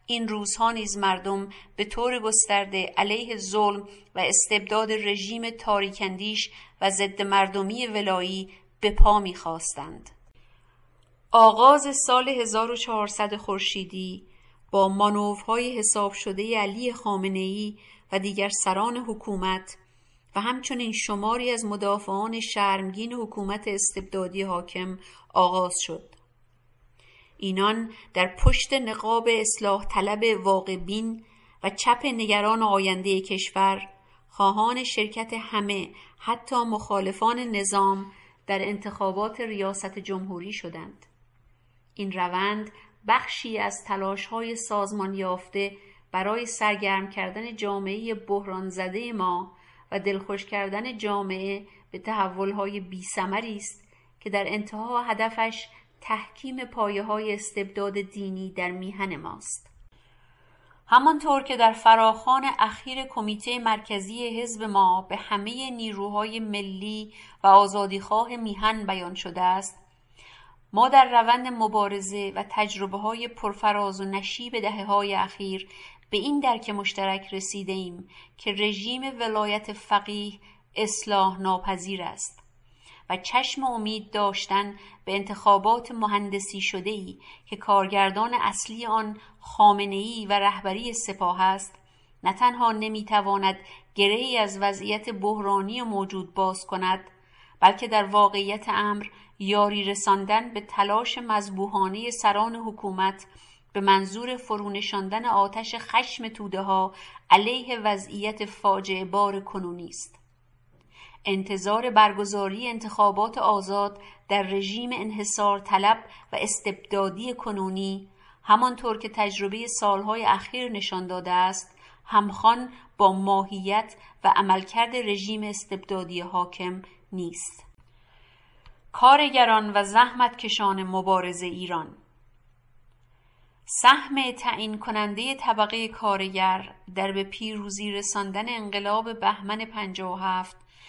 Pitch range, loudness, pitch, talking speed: 195-220 Hz, -25 LUFS, 205 Hz, 105 wpm